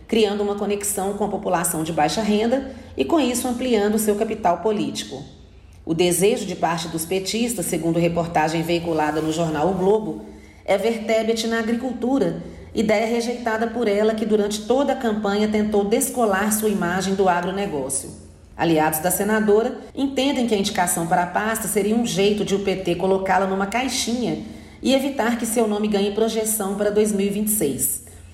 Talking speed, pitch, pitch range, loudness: 160 wpm, 205 Hz, 180-225 Hz, -21 LUFS